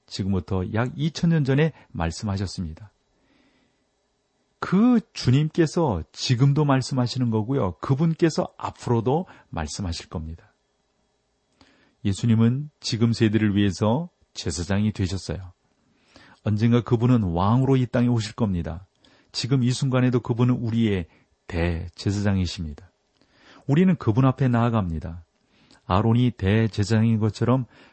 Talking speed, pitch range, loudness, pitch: 275 characters per minute, 95-130 Hz, -23 LUFS, 115 Hz